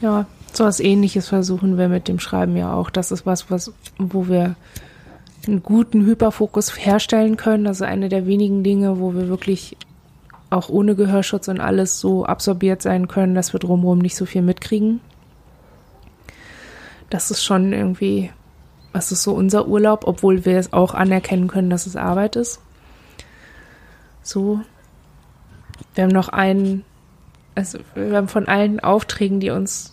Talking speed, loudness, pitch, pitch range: 155 wpm, -18 LUFS, 190 Hz, 180-205 Hz